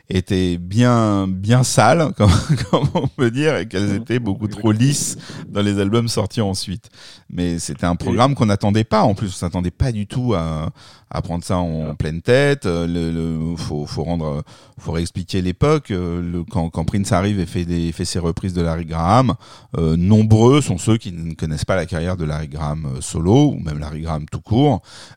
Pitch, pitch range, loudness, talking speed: 95 Hz, 85-115 Hz, -19 LUFS, 200 wpm